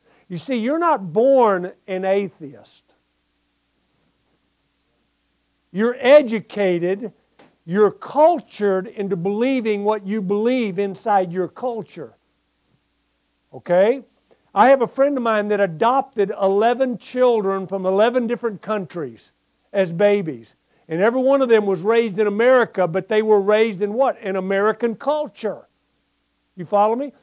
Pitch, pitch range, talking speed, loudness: 210 Hz, 190-240 Hz, 125 wpm, -19 LUFS